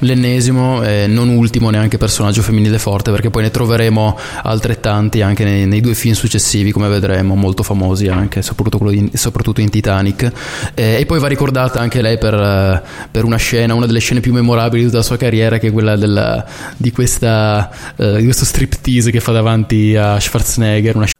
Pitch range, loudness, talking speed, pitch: 105-120 Hz, -13 LUFS, 195 wpm, 110 Hz